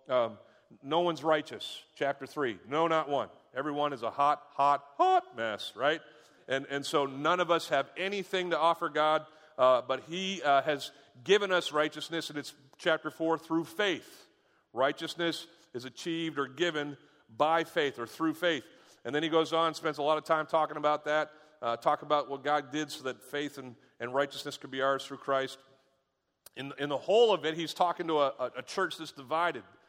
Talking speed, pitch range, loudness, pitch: 195 wpm, 140-165 Hz, -31 LUFS, 150 Hz